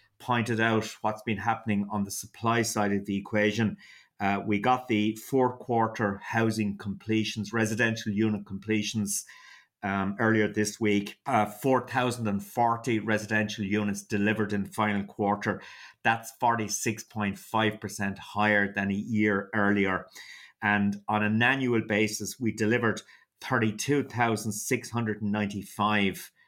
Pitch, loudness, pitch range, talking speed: 105 Hz, -28 LUFS, 100-115 Hz, 115 wpm